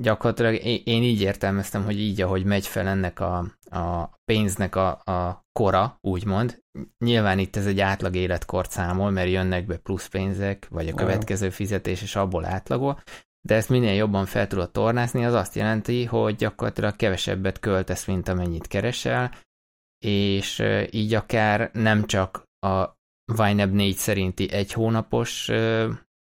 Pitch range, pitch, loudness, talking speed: 95-110 Hz, 100 Hz, -24 LUFS, 145 wpm